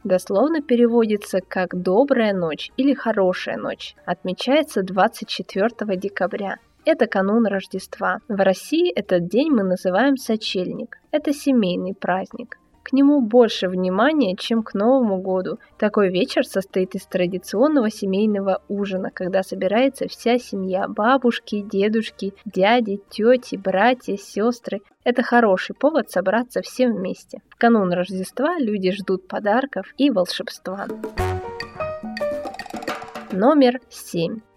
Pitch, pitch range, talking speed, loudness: 210 Hz, 190-250 Hz, 115 wpm, -21 LUFS